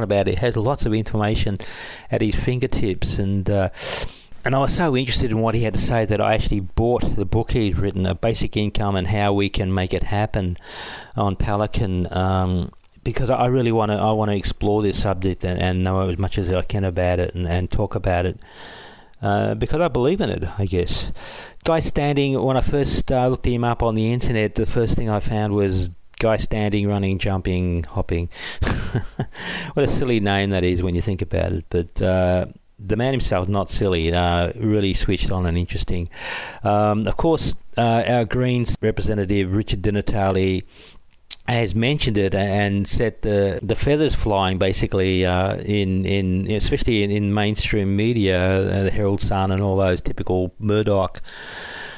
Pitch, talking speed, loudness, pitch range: 100 Hz, 185 wpm, -21 LUFS, 95-115 Hz